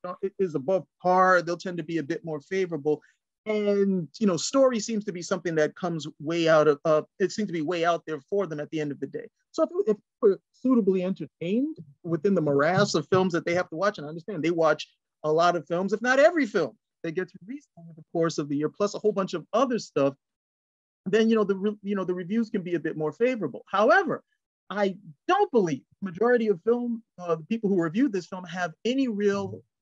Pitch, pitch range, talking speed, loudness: 185 Hz, 160-210 Hz, 235 wpm, -26 LUFS